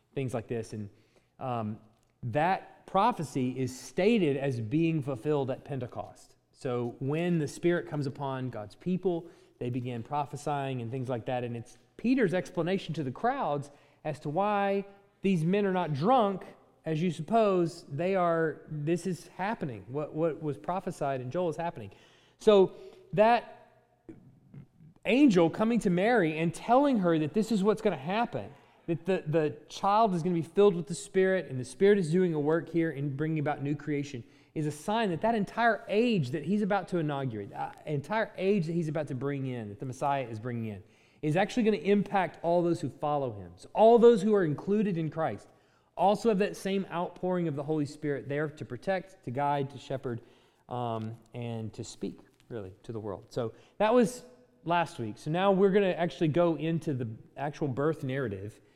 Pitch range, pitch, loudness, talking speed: 135-190 Hz, 160 Hz, -30 LUFS, 190 wpm